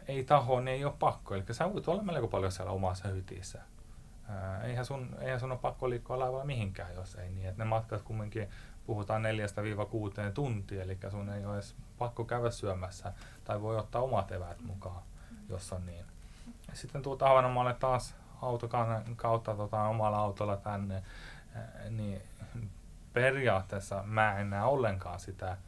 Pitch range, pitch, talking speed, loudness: 95-120 Hz, 110 Hz, 155 wpm, -35 LUFS